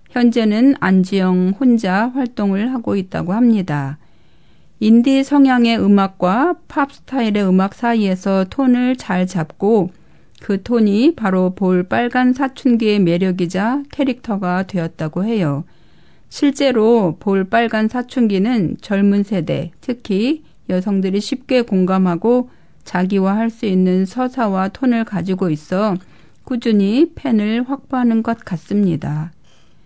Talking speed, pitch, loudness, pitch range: 255 characters per minute, 205 Hz, -16 LUFS, 185-245 Hz